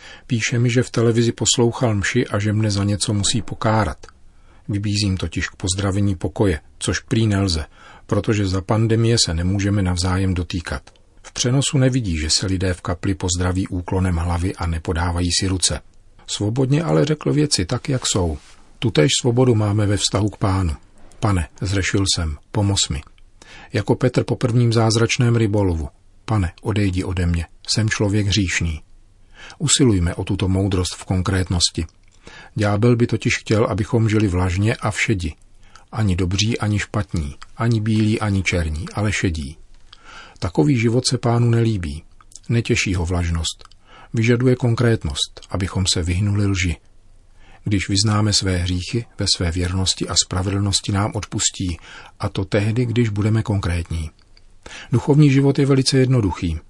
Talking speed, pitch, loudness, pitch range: 145 wpm, 100 Hz, -19 LUFS, 90-115 Hz